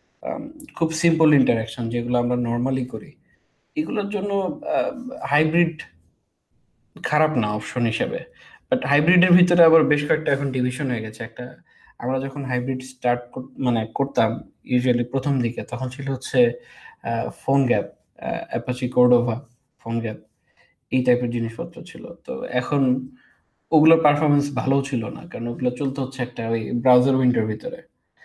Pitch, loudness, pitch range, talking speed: 130 Hz, -22 LUFS, 120-155 Hz, 130 wpm